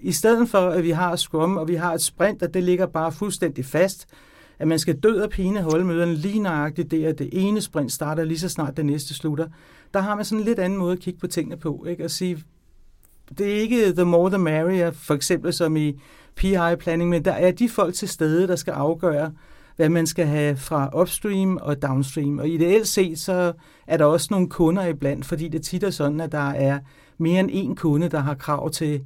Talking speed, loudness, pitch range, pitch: 235 wpm, -22 LUFS, 155-185 Hz, 170 Hz